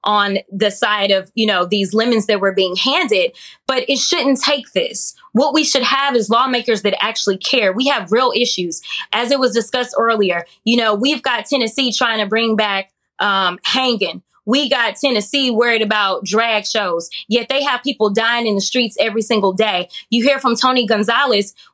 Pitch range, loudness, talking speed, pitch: 205-265 Hz, -16 LUFS, 190 wpm, 230 Hz